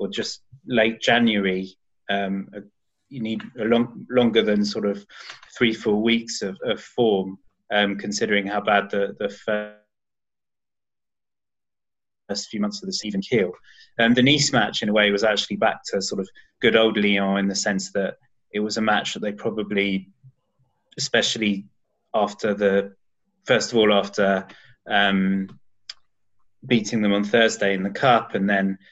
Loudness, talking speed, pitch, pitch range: -22 LUFS, 160 wpm, 105 Hz, 100-115 Hz